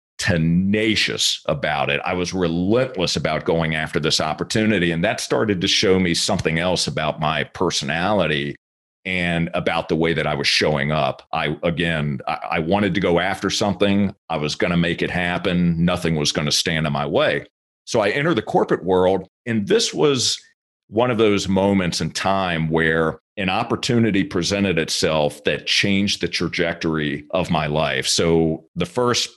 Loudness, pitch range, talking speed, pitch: -20 LUFS, 80-100 Hz, 170 wpm, 90 Hz